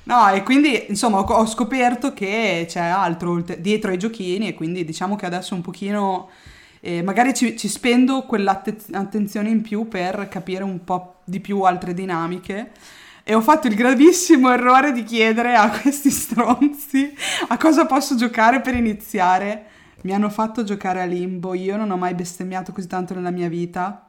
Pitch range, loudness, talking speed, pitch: 185-240 Hz, -19 LUFS, 170 wpm, 205 Hz